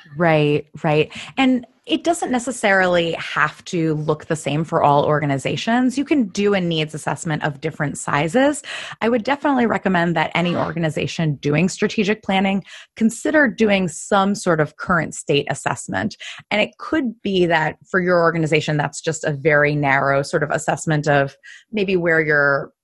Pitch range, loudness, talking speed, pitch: 150-215 Hz, -19 LUFS, 160 wpm, 165 Hz